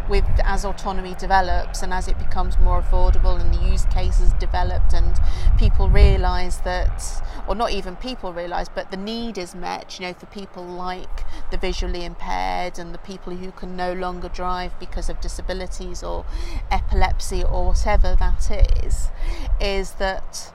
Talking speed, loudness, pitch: 165 wpm, -25 LUFS, 175 Hz